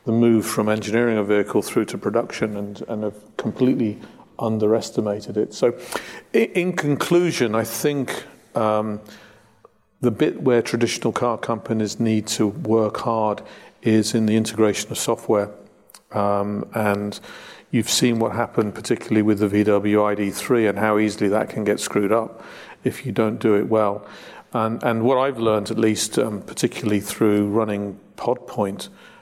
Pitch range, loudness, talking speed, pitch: 105-115 Hz, -21 LUFS, 150 wpm, 110 Hz